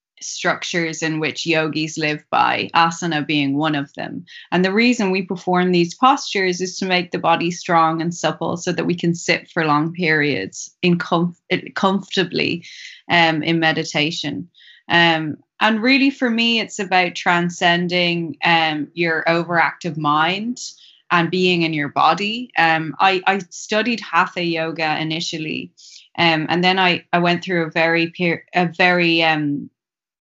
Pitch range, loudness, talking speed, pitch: 160-180 Hz, -18 LUFS, 155 wpm, 170 Hz